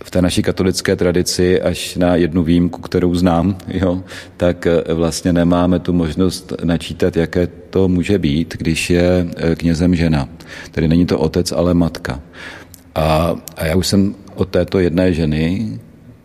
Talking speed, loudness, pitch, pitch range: 150 wpm, -16 LUFS, 90 Hz, 85-90 Hz